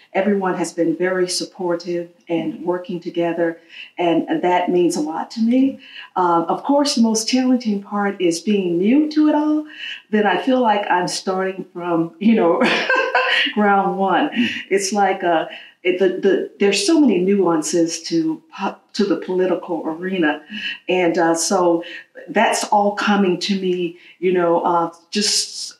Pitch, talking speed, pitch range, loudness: 190 Hz, 155 wpm, 175-230 Hz, -18 LUFS